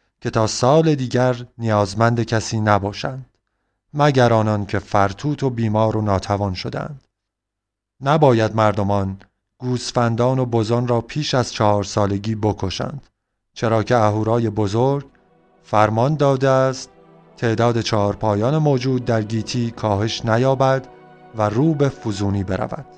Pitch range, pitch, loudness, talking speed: 105-125 Hz, 115 Hz, -19 LUFS, 120 wpm